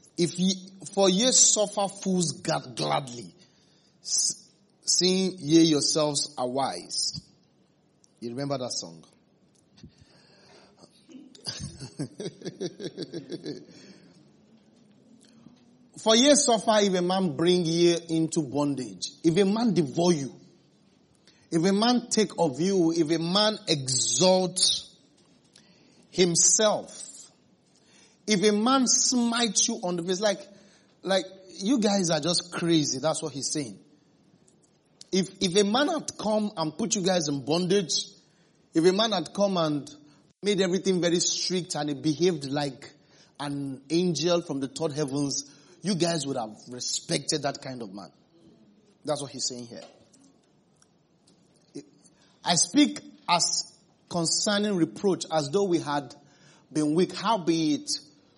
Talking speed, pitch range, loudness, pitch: 125 wpm, 155-200 Hz, -25 LUFS, 175 Hz